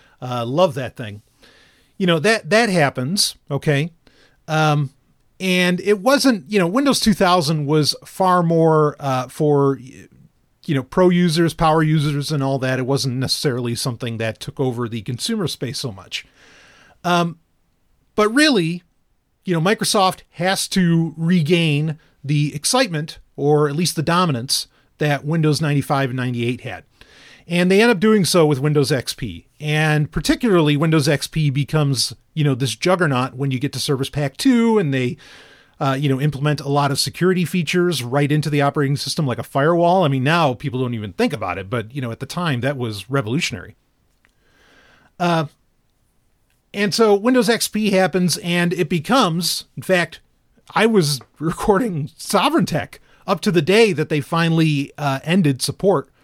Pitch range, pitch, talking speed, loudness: 135-180 Hz, 150 Hz, 165 wpm, -18 LUFS